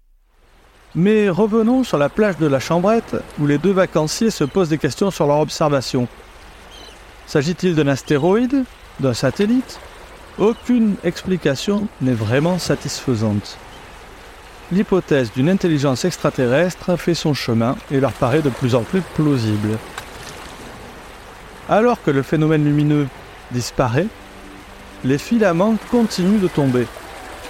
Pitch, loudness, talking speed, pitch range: 155 Hz, -18 LUFS, 120 wpm, 135-190 Hz